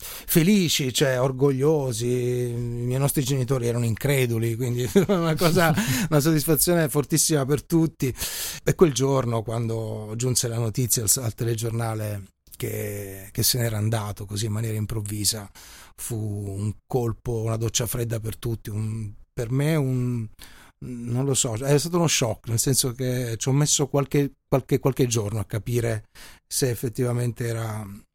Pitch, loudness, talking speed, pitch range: 120 Hz, -24 LUFS, 145 wpm, 110-140 Hz